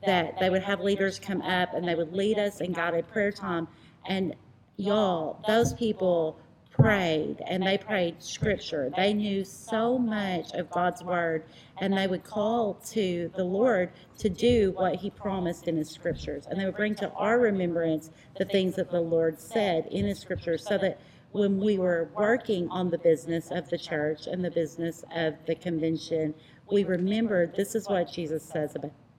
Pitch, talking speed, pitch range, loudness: 180 Hz, 185 wpm, 165-200 Hz, -28 LUFS